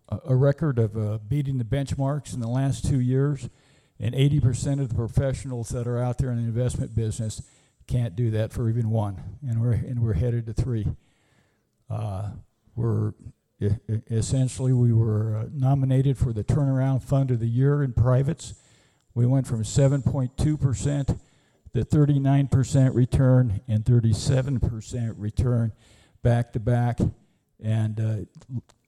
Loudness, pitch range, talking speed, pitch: -25 LUFS, 110-135 Hz, 150 wpm, 120 Hz